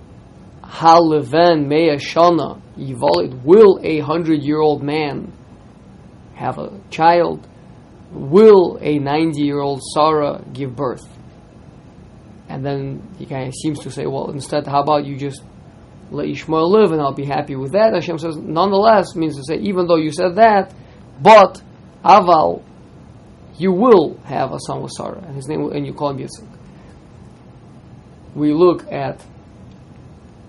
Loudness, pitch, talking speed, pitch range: -15 LUFS, 155 Hz, 140 wpm, 145-170 Hz